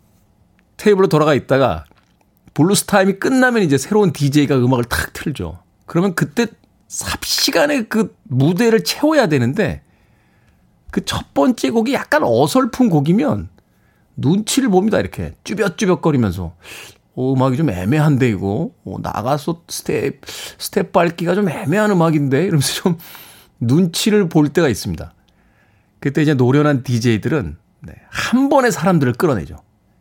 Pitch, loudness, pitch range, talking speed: 155 Hz, -16 LUFS, 120-200 Hz, 305 characters per minute